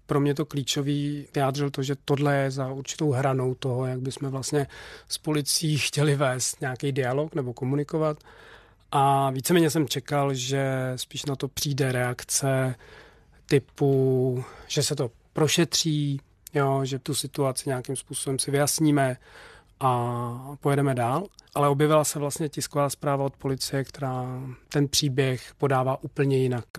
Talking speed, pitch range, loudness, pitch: 145 wpm, 130-145 Hz, -26 LUFS, 140 Hz